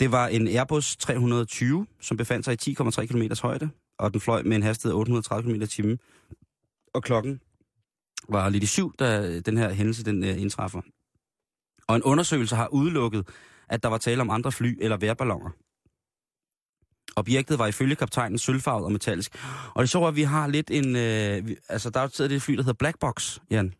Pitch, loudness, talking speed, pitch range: 115 Hz, -26 LUFS, 190 wpm, 110-130 Hz